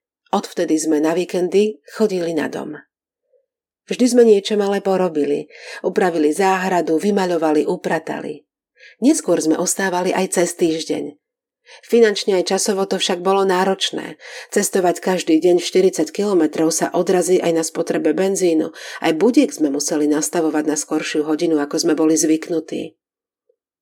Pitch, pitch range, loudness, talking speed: 180 Hz, 160-195 Hz, -18 LUFS, 130 wpm